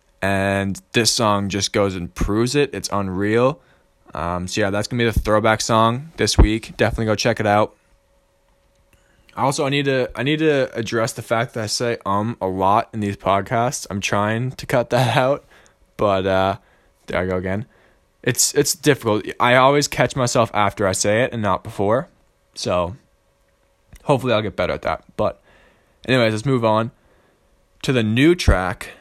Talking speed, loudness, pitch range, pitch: 180 wpm, -19 LUFS, 100-125 Hz, 110 Hz